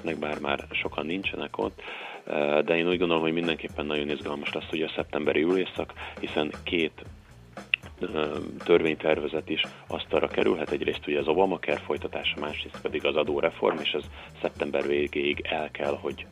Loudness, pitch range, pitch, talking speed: -28 LUFS, 75-80 Hz, 75 Hz, 155 wpm